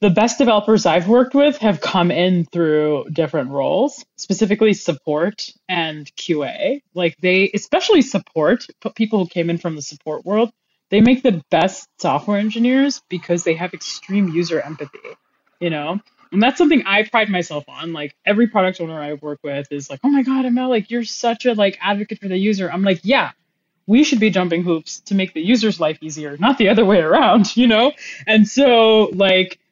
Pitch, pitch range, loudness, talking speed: 200 Hz, 170-235 Hz, -17 LUFS, 190 wpm